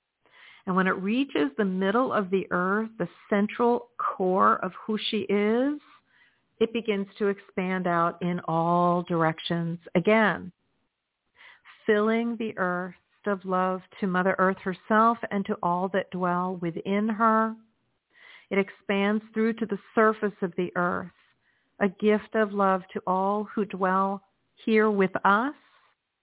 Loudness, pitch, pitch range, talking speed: -26 LUFS, 200 Hz, 185-220 Hz, 140 wpm